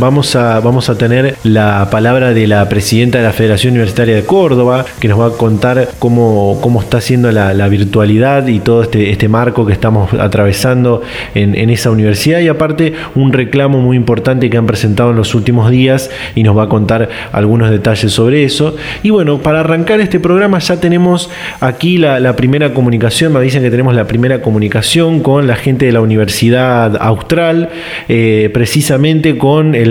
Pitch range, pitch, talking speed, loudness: 110-140 Hz, 120 Hz, 185 wpm, -10 LUFS